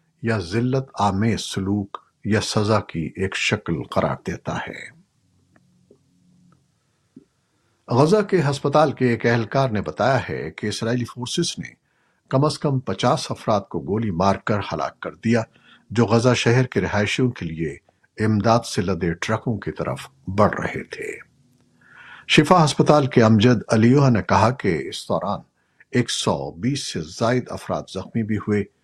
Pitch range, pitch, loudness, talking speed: 105-140 Hz, 120 Hz, -21 LUFS, 150 wpm